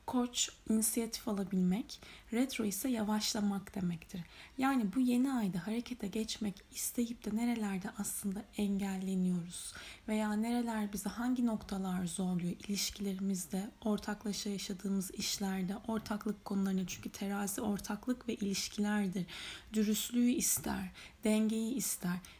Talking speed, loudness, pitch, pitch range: 105 wpm, -36 LUFS, 210 Hz, 195-225 Hz